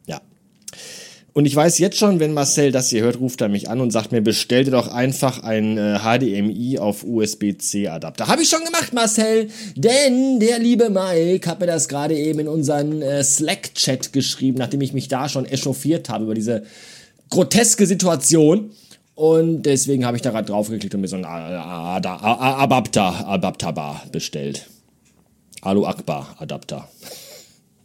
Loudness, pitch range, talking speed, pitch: -19 LUFS, 110-170 Hz, 155 wpm, 135 Hz